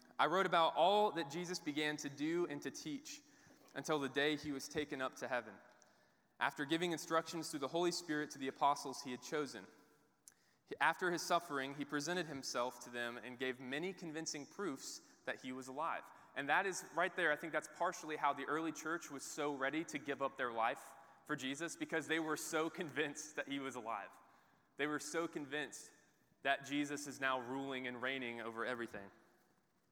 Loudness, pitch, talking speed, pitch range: -41 LUFS, 150 Hz, 195 wpm, 135-160 Hz